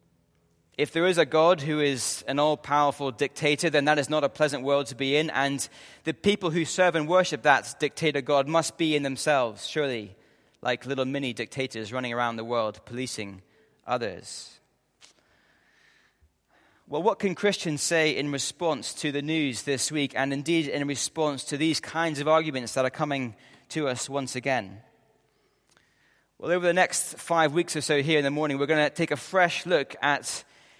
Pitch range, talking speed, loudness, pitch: 130-160 Hz, 185 wpm, -26 LUFS, 145 Hz